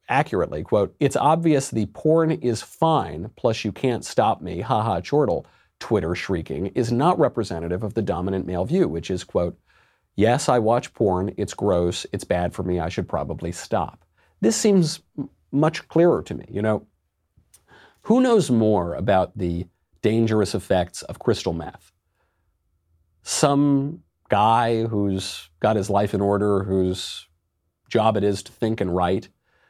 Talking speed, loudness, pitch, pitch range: 160 wpm, -22 LUFS, 100 Hz, 90-120 Hz